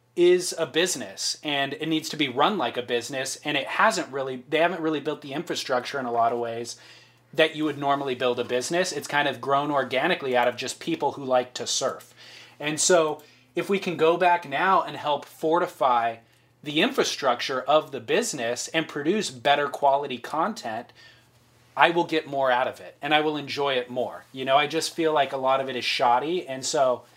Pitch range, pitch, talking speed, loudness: 125-160 Hz, 140 Hz, 210 wpm, -25 LUFS